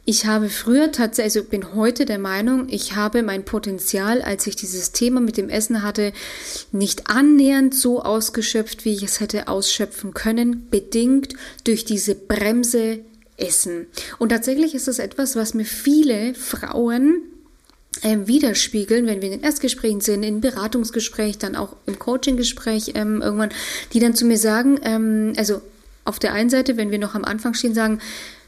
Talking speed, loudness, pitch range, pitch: 165 wpm, -20 LUFS, 210-245 Hz, 225 Hz